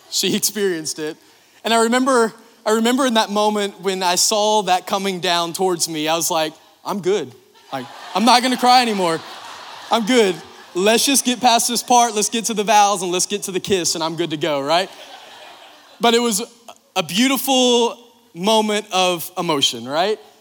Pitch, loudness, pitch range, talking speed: 210 Hz, -17 LUFS, 180-235 Hz, 190 wpm